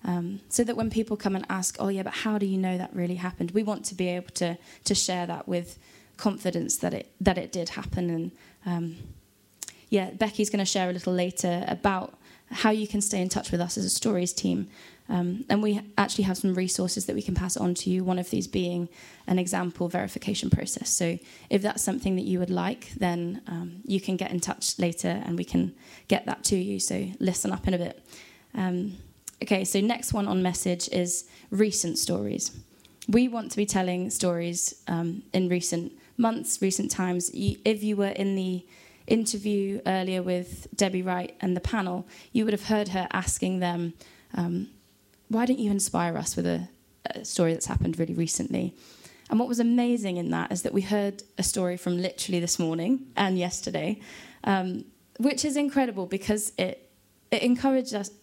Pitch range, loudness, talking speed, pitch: 180-210 Hz, -28 LUFS, 200 wpm, 190 Hz